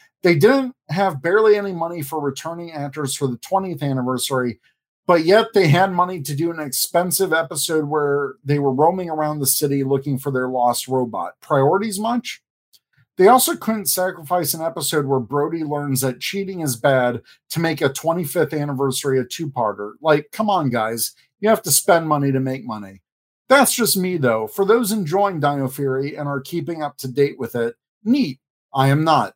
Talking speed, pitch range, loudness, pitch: 185 wpm, 135-185 Hz, -19 LUFS, 150 Hz